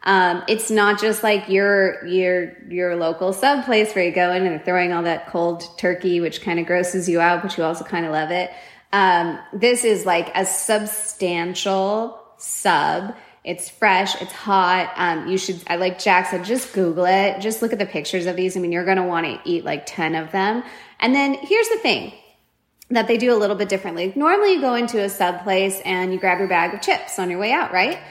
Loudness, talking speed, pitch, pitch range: -20 LUFS, 225 wpm, 190 Hz, 180-215 Hz